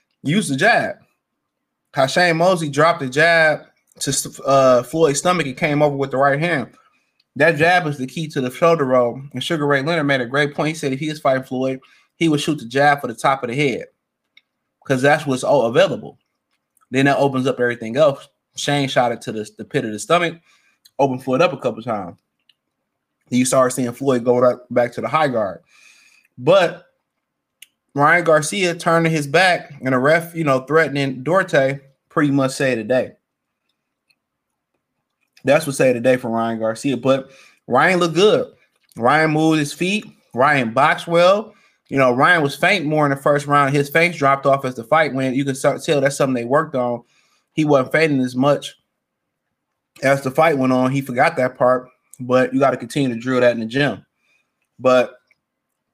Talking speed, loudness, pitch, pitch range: 195 wpm, -17 LUFS, 140 Hz, 130-155 Hz